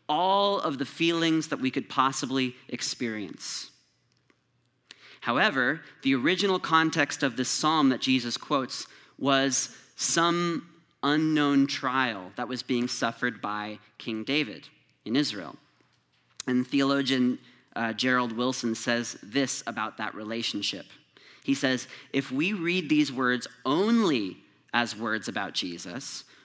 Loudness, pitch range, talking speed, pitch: -27 LUFS, 120-150 Hz, 125 wpm, 130 Hz